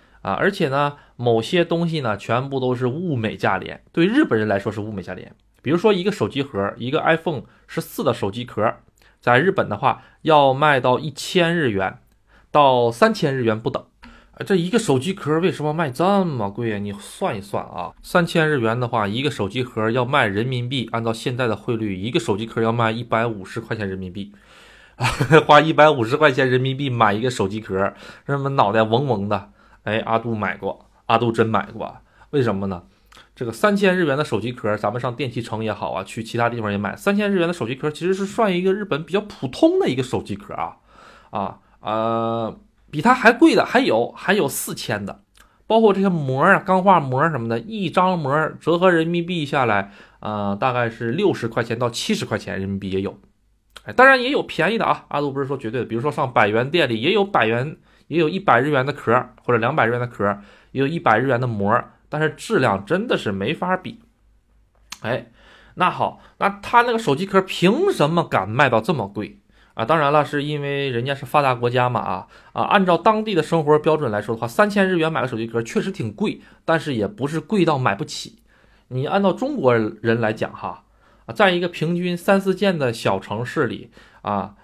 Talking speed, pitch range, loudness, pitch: 310 characters per minute, 110-170 Hz, -20 LUFS, 130 Hz